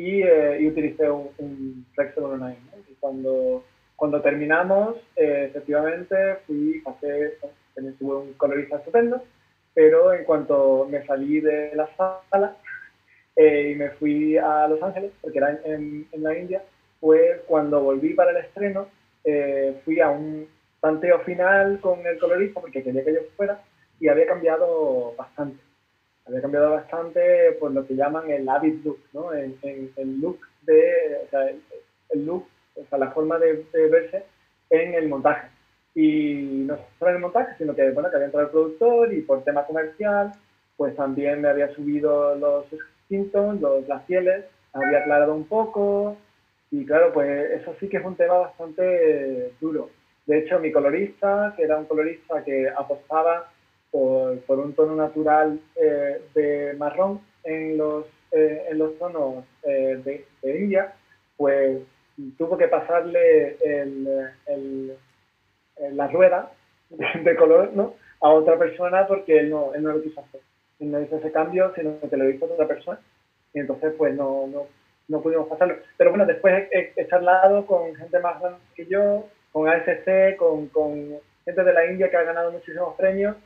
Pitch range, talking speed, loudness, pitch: 145-190 Hz, 170 wpm, -22 LUFS, 155 Hz